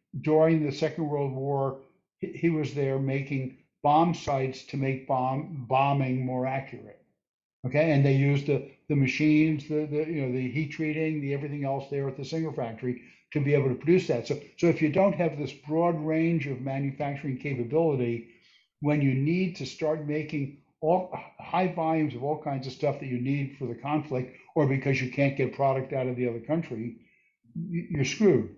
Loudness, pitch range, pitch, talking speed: -28 LUFS, 135-155 Hz, 140 Hz, 190 wpm